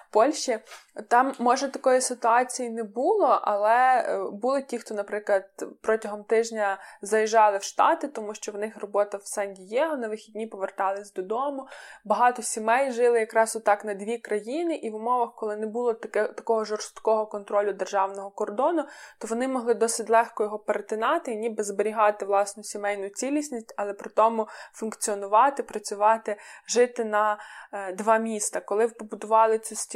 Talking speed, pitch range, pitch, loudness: 150 wpm, 210-240 Hz, 220 Hz, -26 LUFS